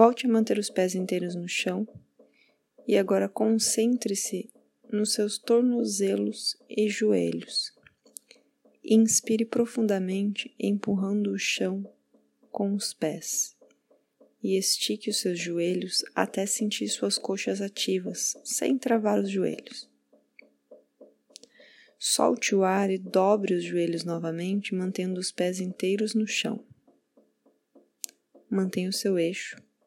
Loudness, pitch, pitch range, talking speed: -27 LUFS, 195 Hz, 185-215 Hz, 115 wpm